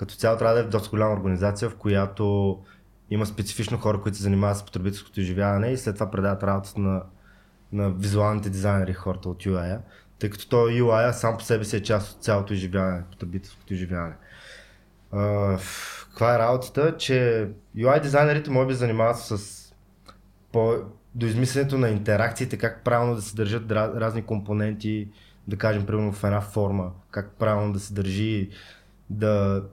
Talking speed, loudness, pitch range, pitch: 165 wpm, -25 LUFS, 100-115 Hz, 105 Hz